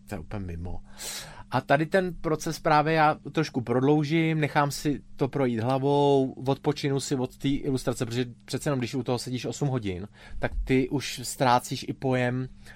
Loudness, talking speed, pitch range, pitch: -27 LUFS, 165 wpm, 125-145 Hz, 135 Hz